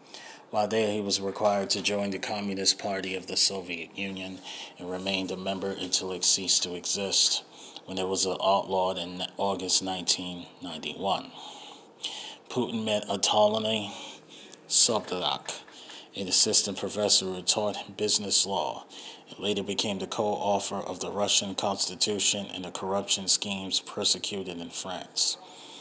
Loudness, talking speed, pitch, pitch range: -26 LUFS, 135 wpm, 95 Hz, 95-100 Hz